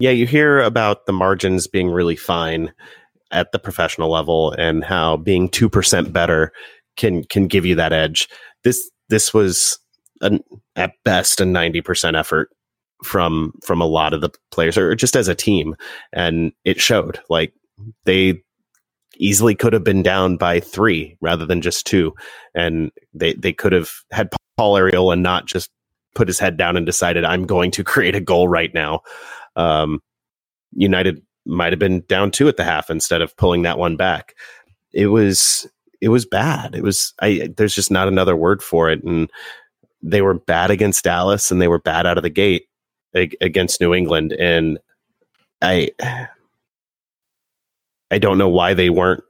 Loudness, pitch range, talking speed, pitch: -17 LUFS, 85-100 Hz, 175 wpm, 90 Hz